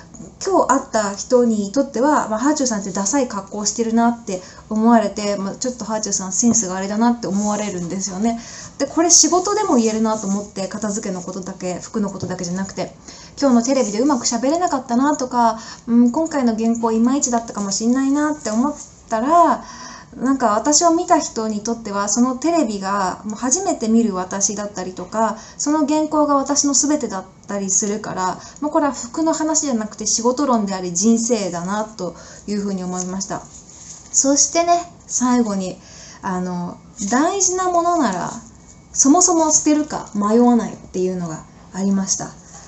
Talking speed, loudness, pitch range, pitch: 375 characters per minute, -18 LUFS, 200-280 Hz, 230 Hz